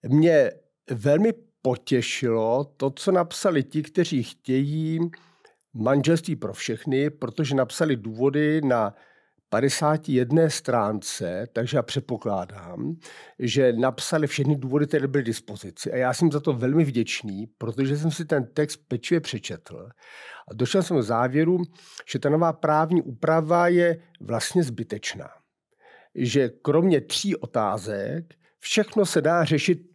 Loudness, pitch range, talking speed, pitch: -24 LUFS, 125-165 Hz, 125 wpm, 145 Hz